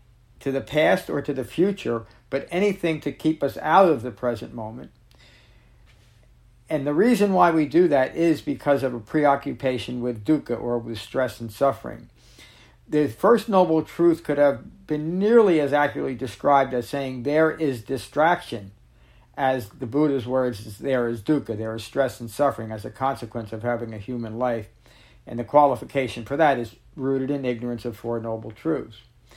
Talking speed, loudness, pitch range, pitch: 175 wpm, -23 LUFS, 115-145 Hz, 130 Hz